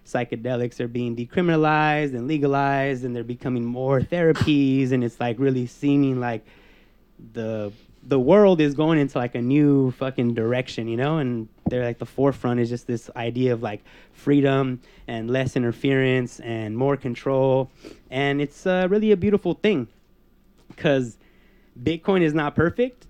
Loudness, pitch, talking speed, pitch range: -22 LUFS, 130 Hz, 155 wpm, 120-145 Hz